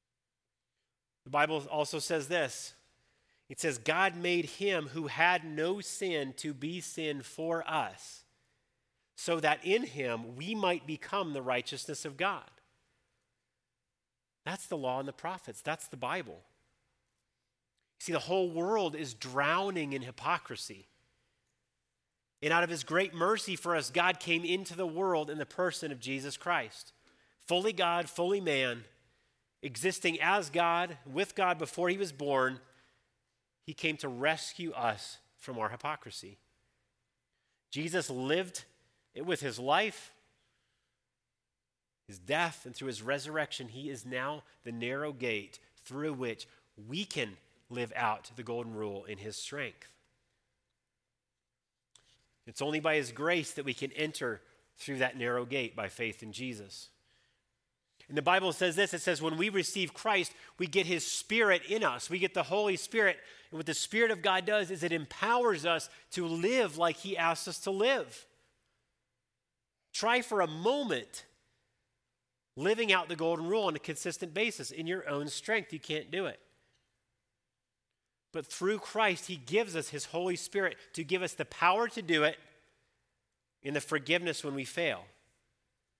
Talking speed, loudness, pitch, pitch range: 155 wpm, -33 LUFS, 155 Hz, 125-175 Hz